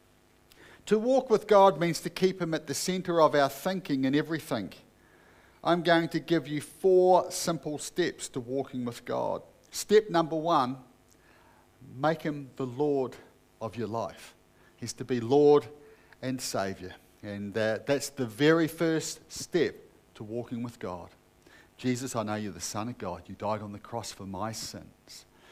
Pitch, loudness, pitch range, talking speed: 135 Hz, -29 LUFS, 110-165 Hz, 165 wpm